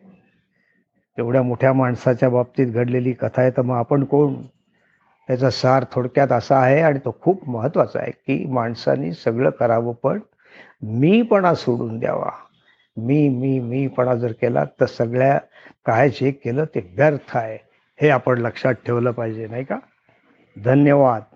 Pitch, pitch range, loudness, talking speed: 130 Hz, 120-140 Hz, -19 LUFS, 140 wpm